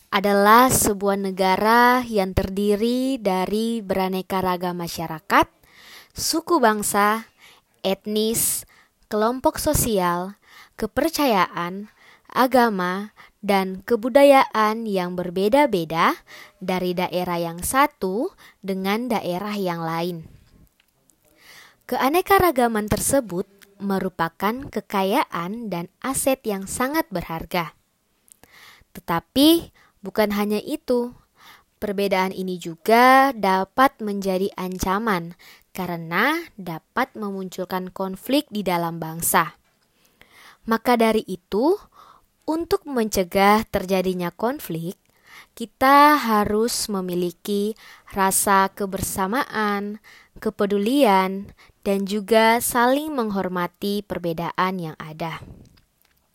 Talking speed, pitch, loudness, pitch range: 80 wpm, 205 Hz, -21 LUFS, 185-235 Hz